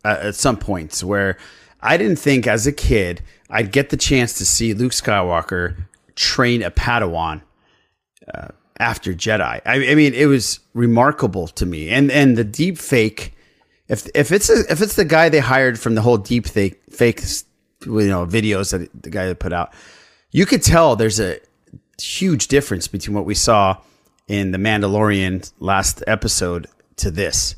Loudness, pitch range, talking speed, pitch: -17 LUFS, 95-130 Hz, 175 wpm, 105 Hz